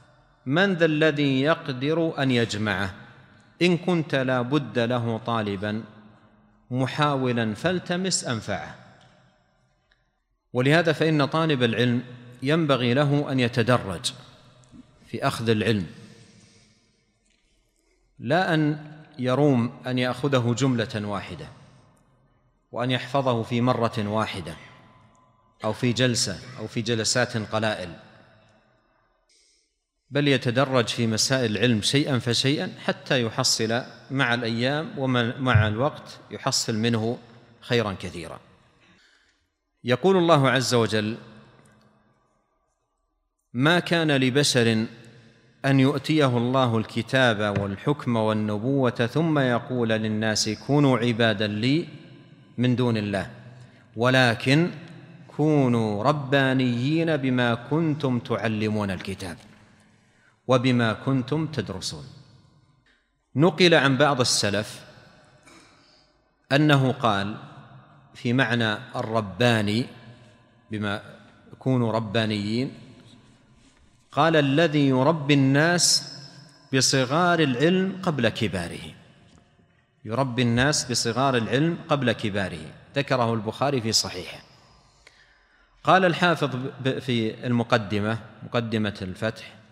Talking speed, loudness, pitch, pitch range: 85 wpm, -23 LUFS, 125 Hz, 115-140 Hz